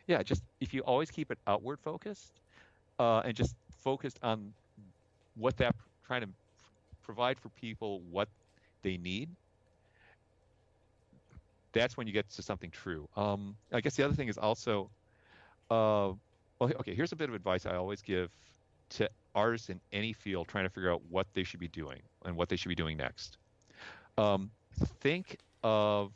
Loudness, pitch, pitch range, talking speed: -35 LUFS, 105 Hz, 95-115 Hz, 170 wpm